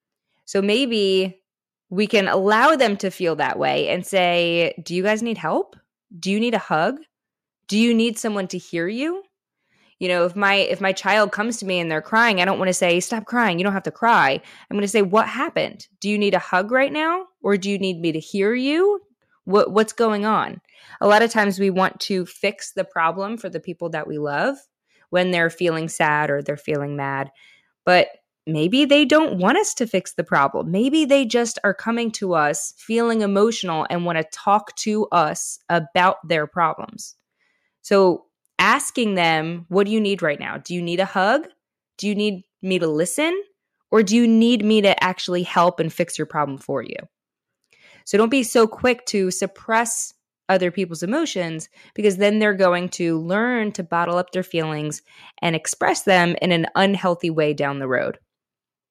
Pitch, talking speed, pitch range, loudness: 195 Hz, 200 wpm, 175-220 Hz, -20 LUFS